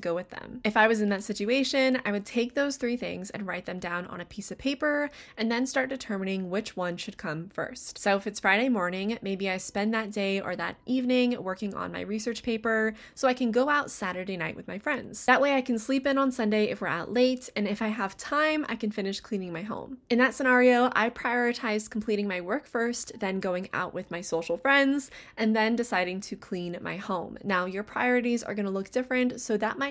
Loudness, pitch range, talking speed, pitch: -28 LUFS, 195-250 Hz, 235 wpm, 220 Hz